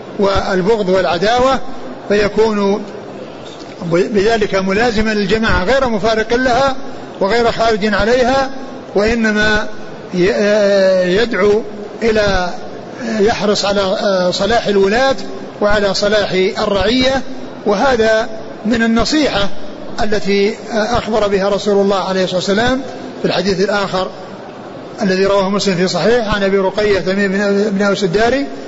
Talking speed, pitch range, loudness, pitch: 100 wpm, 200-230 Hz, -14 LUFS, 210 Hz